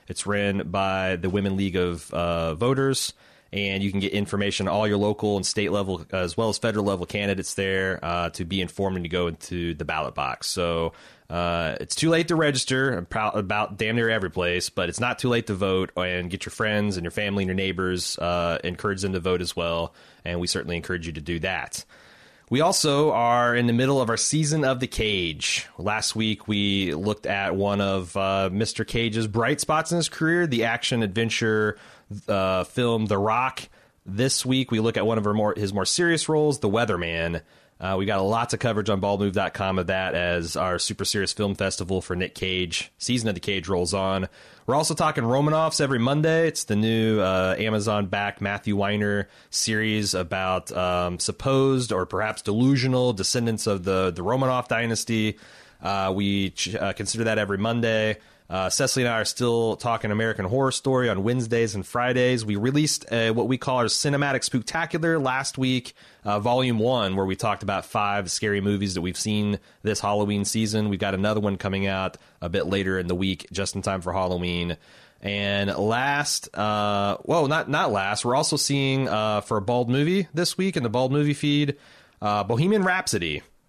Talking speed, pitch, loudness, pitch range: 195 wpm, 105 Hz, -24 LUFS, 95-120 Hz